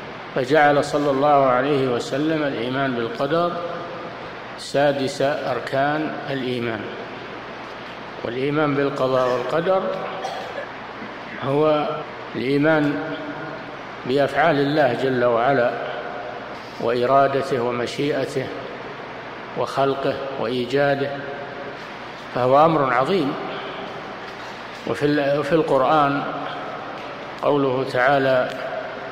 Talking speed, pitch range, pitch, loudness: 65 wpm, 130-150 Hz, 140 Hz, -21 LUFS